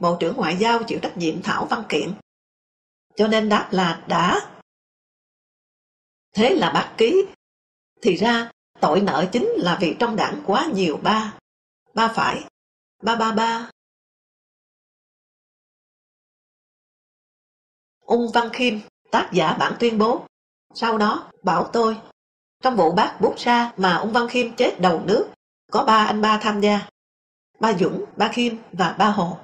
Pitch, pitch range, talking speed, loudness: 225 Hz, 200-235 Hz, 150 wpm, -21 LUFS